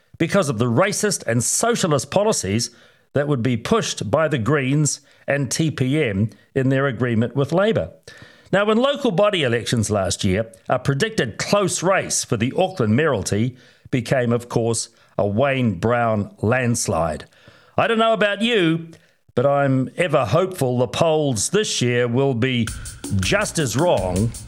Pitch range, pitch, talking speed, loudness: 115-160 Hz, 130 Hz, 150 wpm, -20 LUFS